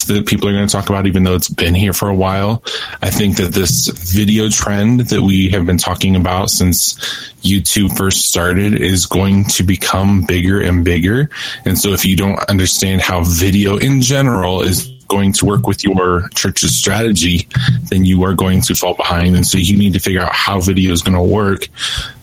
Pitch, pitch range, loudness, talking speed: 95 Hz, 90-100 Hz, -13 LUFS, 205 wpm